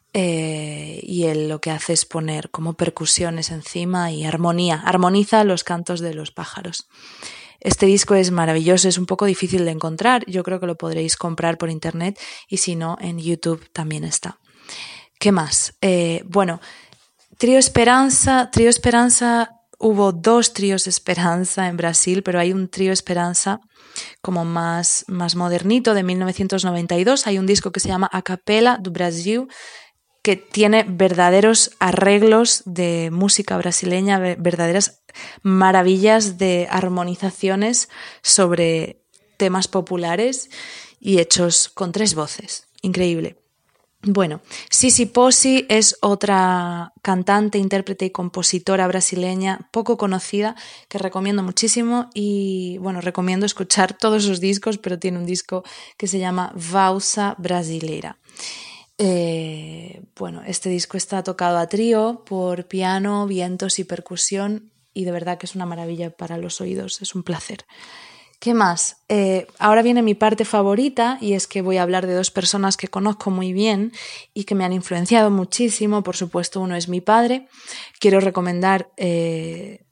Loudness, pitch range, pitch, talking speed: -18 LUFS, 175-205 Hz, 190 Hz, 145 wpm